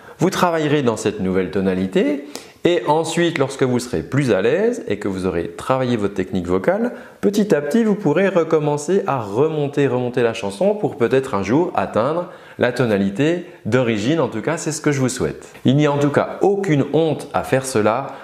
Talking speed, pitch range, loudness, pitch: 200 wpm, 110-160 Hz, -19 LUFS, 135 Hz